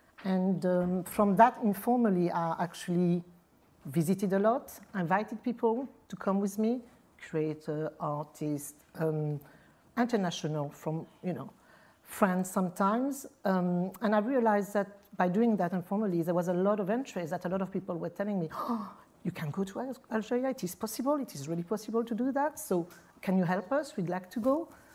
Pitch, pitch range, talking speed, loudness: 195 Hz, 175-230 Hz, 175 wpm, -32 LUFS